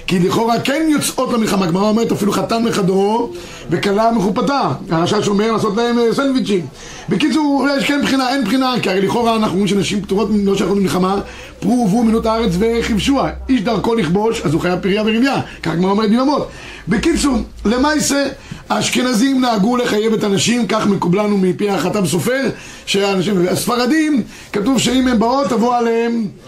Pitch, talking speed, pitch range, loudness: 220 Hz, 155 wpm, 195-250 Hz, -15 LUFS